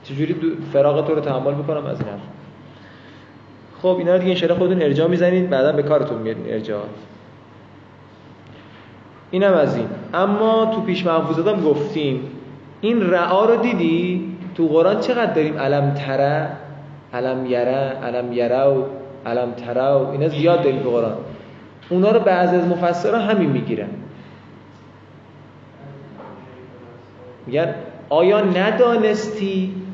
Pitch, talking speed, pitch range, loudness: 150 Hz, 130 wpm, 130-180 Hz, -19 LUFS